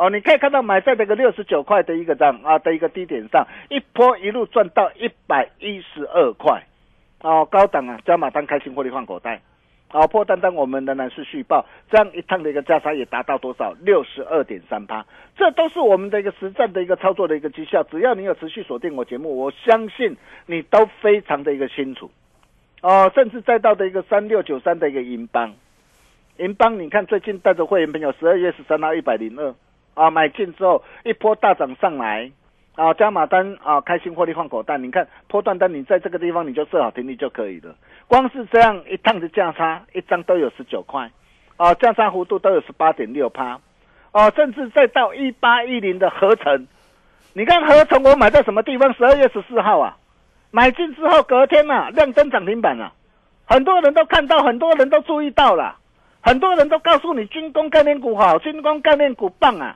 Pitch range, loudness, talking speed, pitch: 160-255 Hz, -17 LUFS, 315 characters per minute, 200 Hz